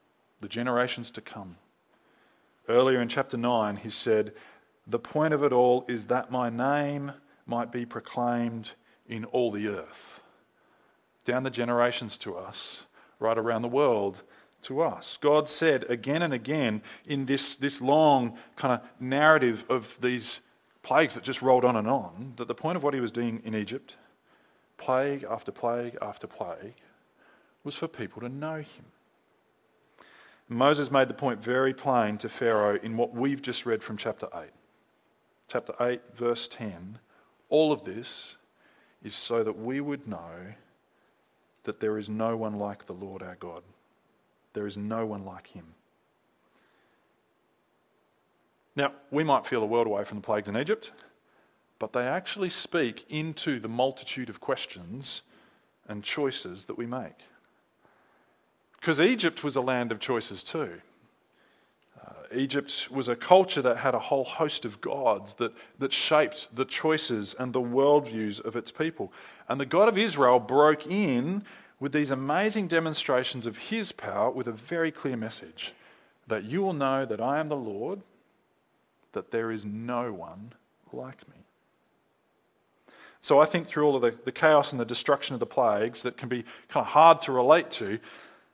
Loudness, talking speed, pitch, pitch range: -28 LUFS, 165 wpm, 125 Hz, 115-145 Hz